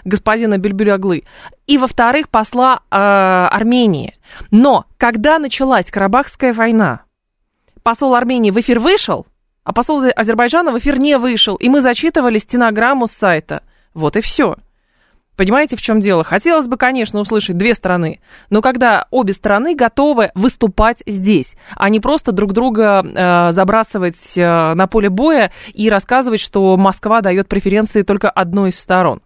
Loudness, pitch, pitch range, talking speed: -13 LUFS, 220 Hz, 195-250 Hz, 145 wpm